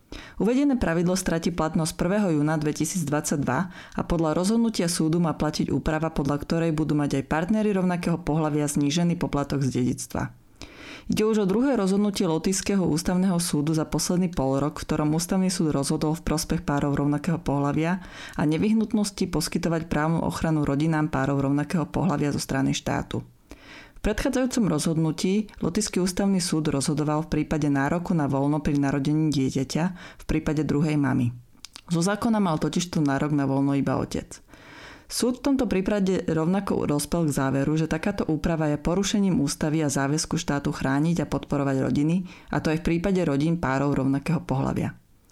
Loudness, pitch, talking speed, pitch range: -25 LUFS, 155 Hz, 155 wpm, 145-185 Hz